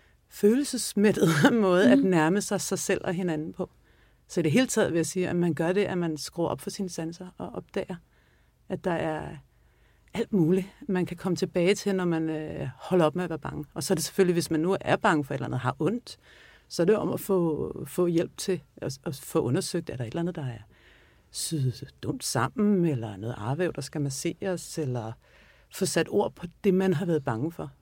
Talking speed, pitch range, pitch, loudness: 220 wpm, 150-190 Hz, 170 Hz, -27 LUFS